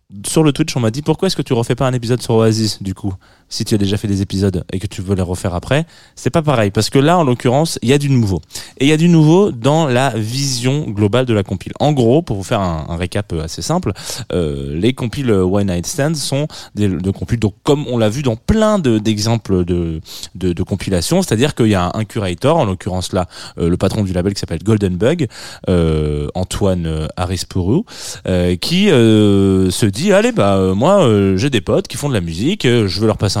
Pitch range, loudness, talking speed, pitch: 95-130 Hz, -15 LUFS, 240 wpm, 105 Hz